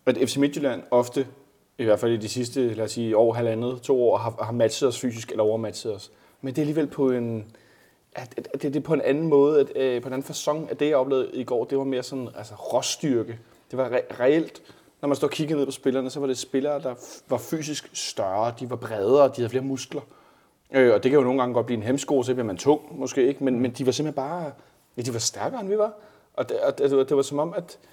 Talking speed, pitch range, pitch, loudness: 265 wpm, 120-140 Hz, 130 Hz, -25 LUFS